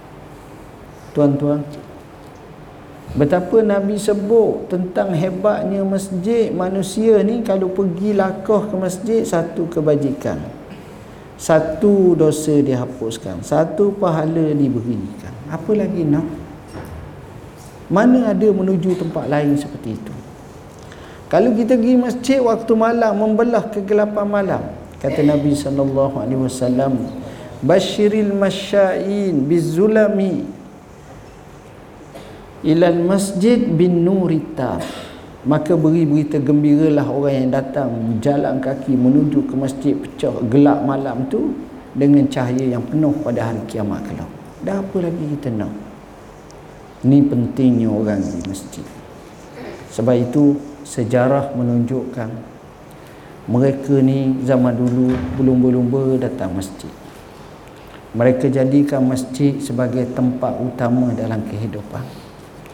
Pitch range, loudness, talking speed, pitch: 130-190 Hz, -17 LUFS, 100 wpm, 145 Hz